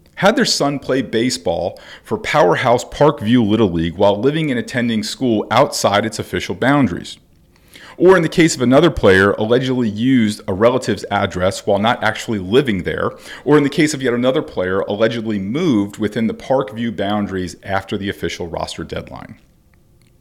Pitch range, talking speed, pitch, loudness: 105-130 Hz, 165 wpm, 115 Hz, -16 LUFS